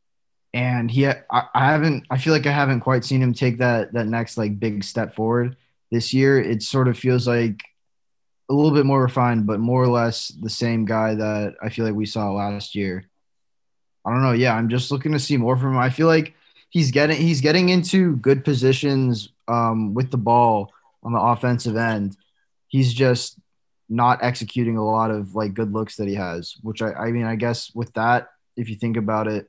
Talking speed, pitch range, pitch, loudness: 210 wpm, 110-130 Hz, 120 Hz, -21 LUFS